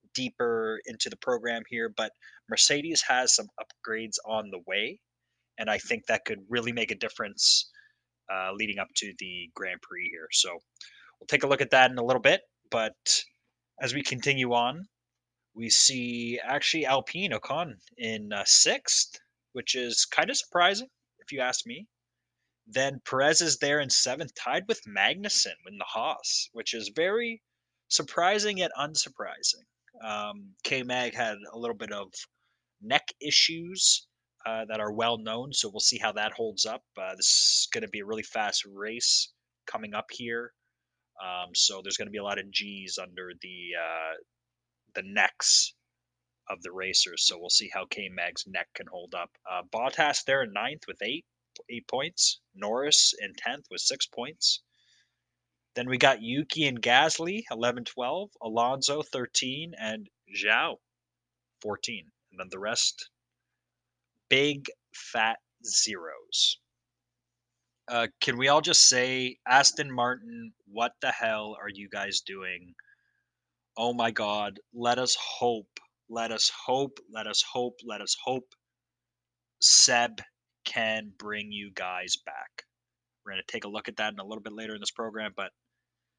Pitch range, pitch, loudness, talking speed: 105-135 Hz, 120 Hz, -26 LUFS, 160 wpm